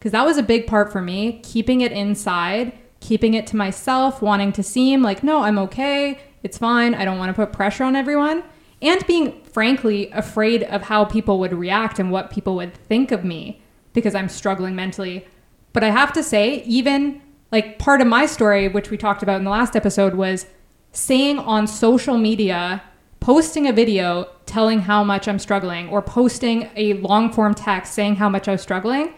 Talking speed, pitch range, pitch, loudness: 195 wpm, 200-250 Hz, 215 Hz, -19 LUFS